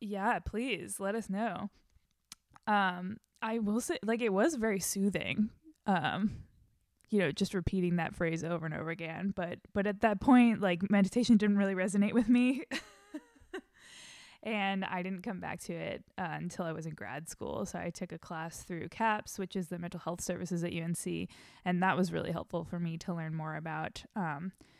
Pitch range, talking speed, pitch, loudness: 175-220 Hz, 190 wpm, 195 Hz, -33 LUFS